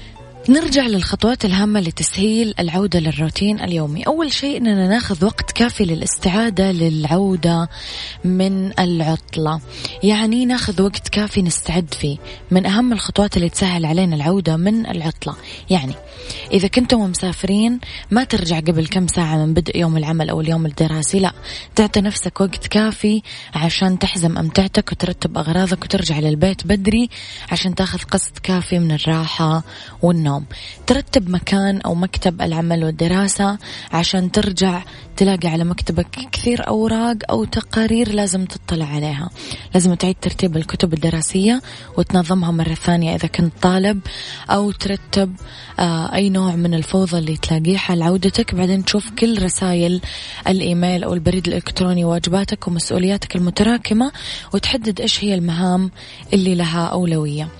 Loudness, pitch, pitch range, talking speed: -18 LUFS, 185 Hz, 170-200 Hz, 130 wpm